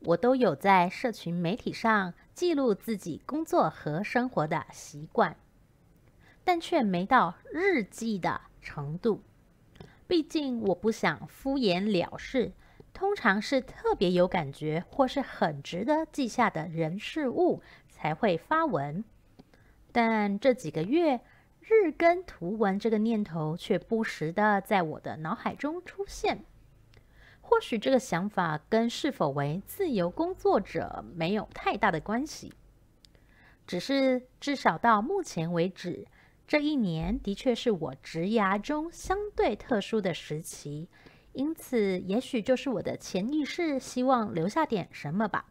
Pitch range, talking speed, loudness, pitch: 175-275 Hz, 205 characters per minute, -29 LUFS, 220 Hz